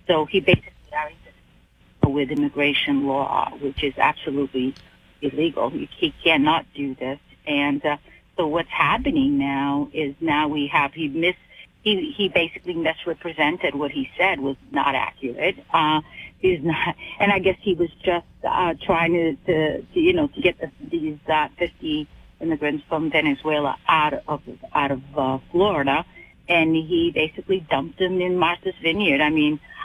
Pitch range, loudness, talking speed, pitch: 145-180 Hz, -22 LUFS, 155 wpm, 160 Hz